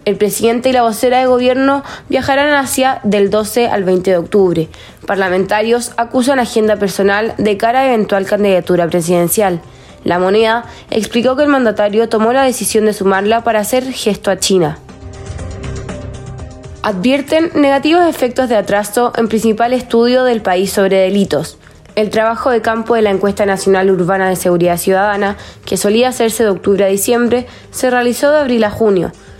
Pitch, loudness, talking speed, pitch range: 215 Hz, -13 LUFS, 160 wpm, 195-245 Hz